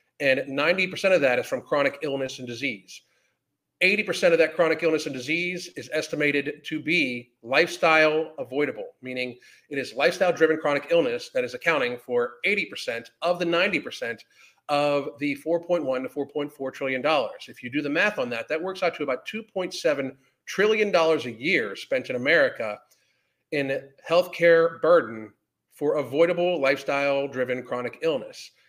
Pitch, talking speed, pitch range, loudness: 155 Hz, 155 wpm, 135-175 Hz, -24 LUFS